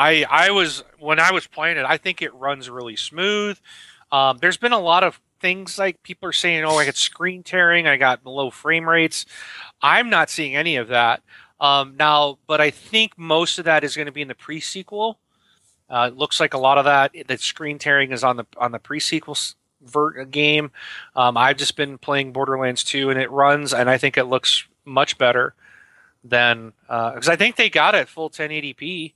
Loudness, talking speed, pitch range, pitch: -19 LUFS, 210 wpm, 135-170 Hz, 150 Hz